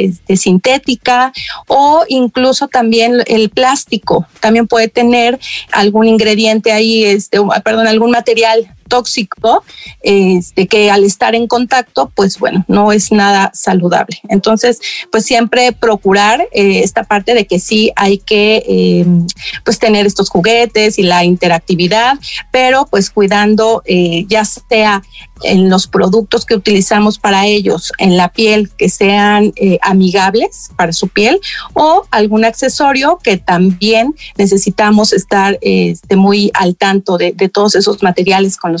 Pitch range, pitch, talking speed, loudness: 195-230 Hz, 210 Hz, 145 wpm, -10 LUFS